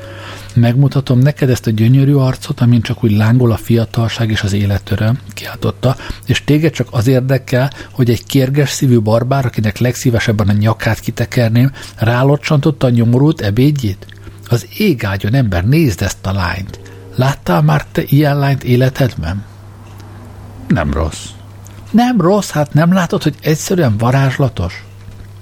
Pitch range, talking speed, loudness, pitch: 105-135 Hz, 135 wpm, -14 LUFS, 120 Hz